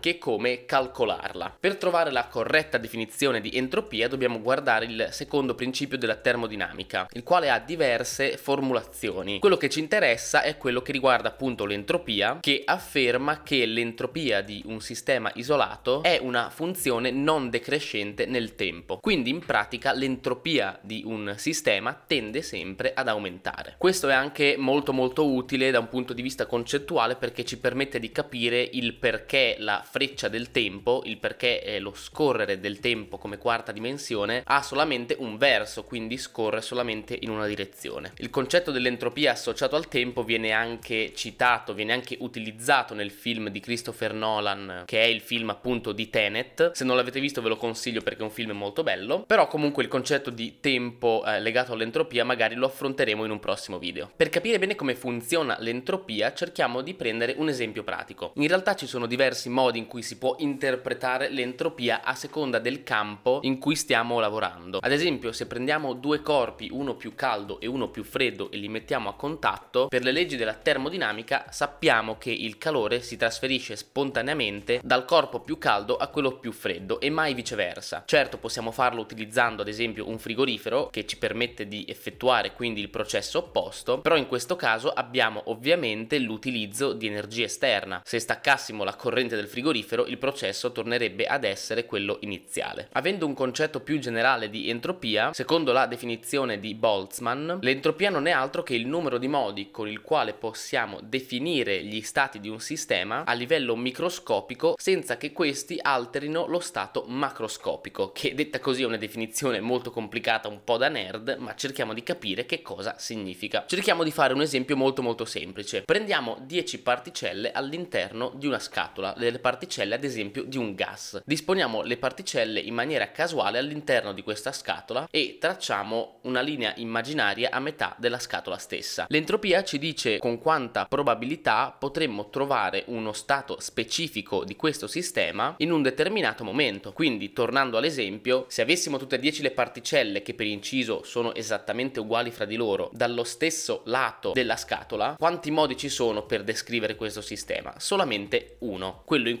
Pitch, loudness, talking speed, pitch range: 125 Hz, -27 LUFS, 170 wpm, 115-145 Hz